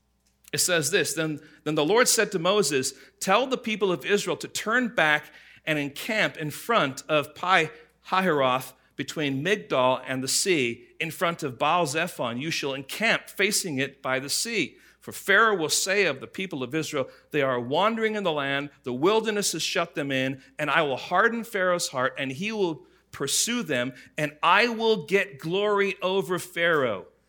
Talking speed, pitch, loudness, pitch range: 180 wpm, 155 Hz, -25 LUFS, 140-195 Hz